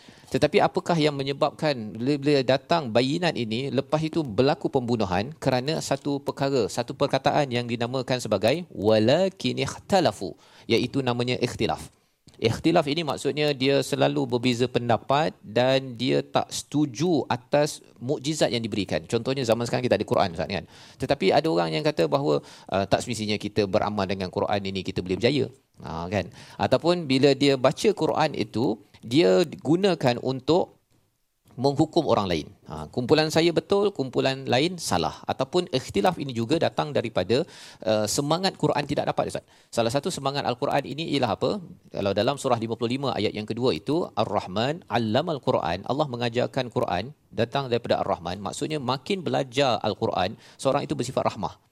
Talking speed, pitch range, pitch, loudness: 145 wpm, 115-150 Hz, 130 Hz, -25 LUFS